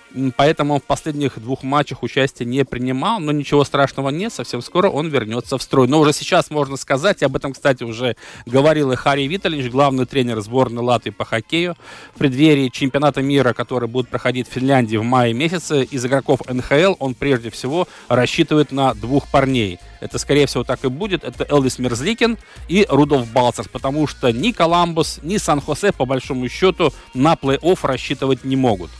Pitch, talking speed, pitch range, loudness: 135 Hz, 180 wpm, 125-150 Hz, -18 LUFS